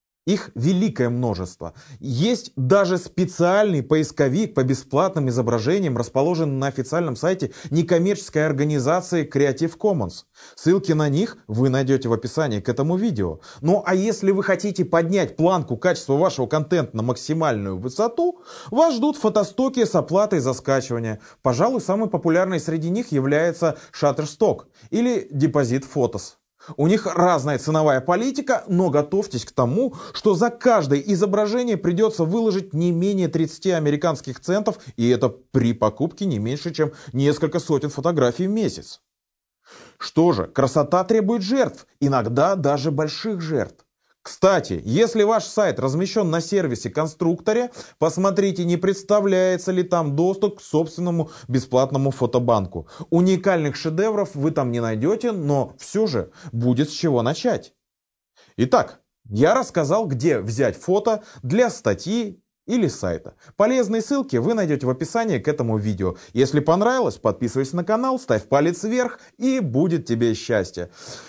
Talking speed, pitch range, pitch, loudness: 135 wpm, 135-200 Hz, 165 Hz, -21 LUFS